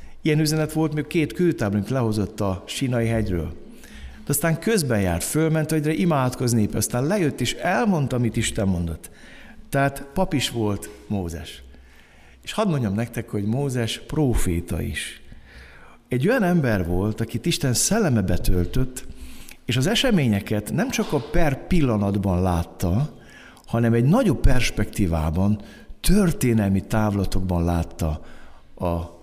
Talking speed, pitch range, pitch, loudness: 125 wpm, 90-150 Hz, 115 Hz, -23 LUFS